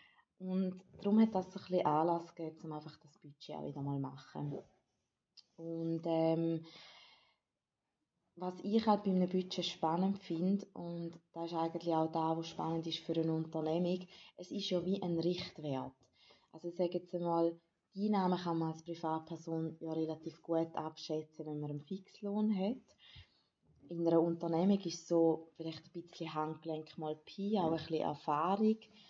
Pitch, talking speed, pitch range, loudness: 165 Hz, 155 wpm, 160-180 Hz, -37 LUFS